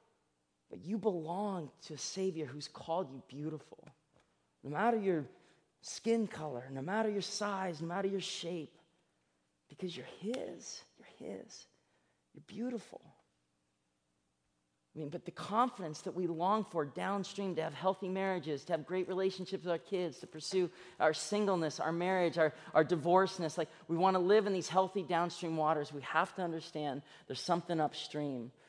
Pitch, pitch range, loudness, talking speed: 170 Hz, 150-190 Hz, -36 LUFS, 155 wpm